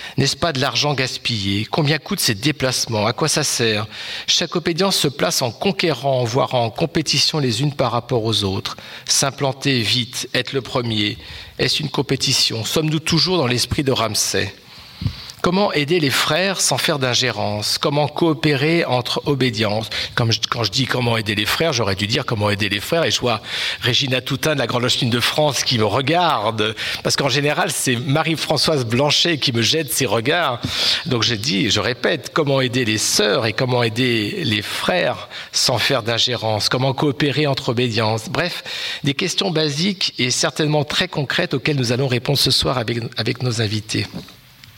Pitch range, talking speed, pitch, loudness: 115-155 Hz, 175 wpm, 130 Hz, -18 LUFS